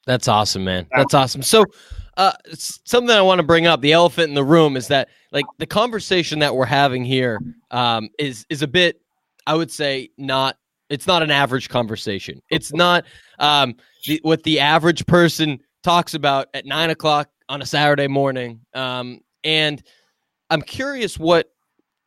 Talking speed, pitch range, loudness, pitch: 170 wpm, 130-165 Hz, -18 LUFS, 145 Hz